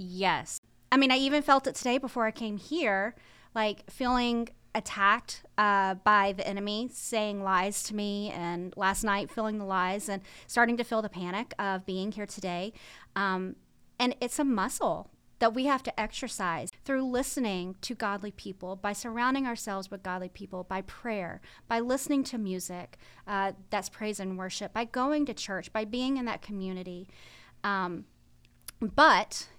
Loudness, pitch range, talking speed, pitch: -30 LUFS, 190-240 Hz, 165 wpm, 205 Hz